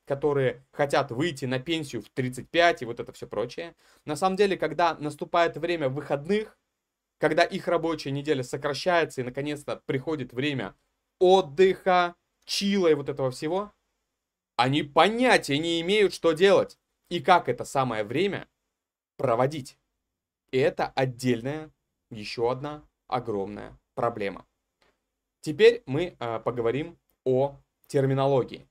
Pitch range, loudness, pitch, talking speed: 130-170 Hz, -26 LUFS, 150 Hz, 120 wpm